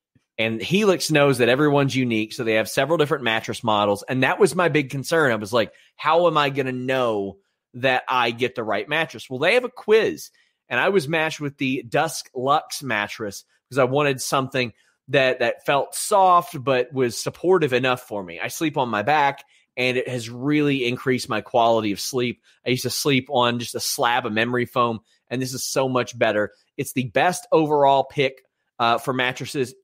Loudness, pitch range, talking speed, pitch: -21 LUFS, 120-150 Hz, 205 wpm, 130 Hz